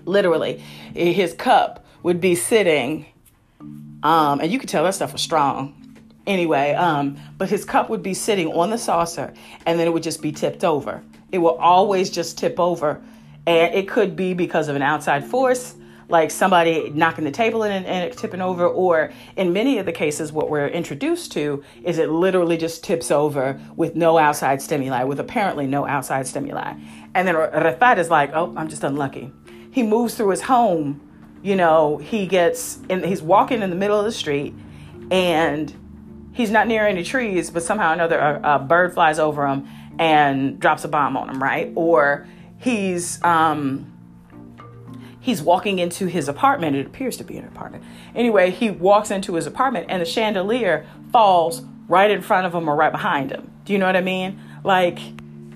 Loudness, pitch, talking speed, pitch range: -20 LUFS, 170 Hz, 190 wpm, 145-190 Hz